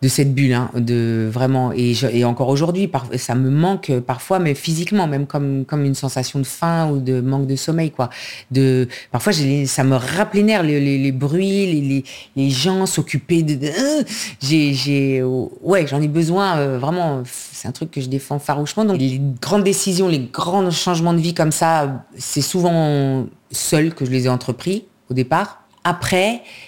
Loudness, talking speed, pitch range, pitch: -18 LUFS, 185 wpm, 130-170 Hz, 145 Hz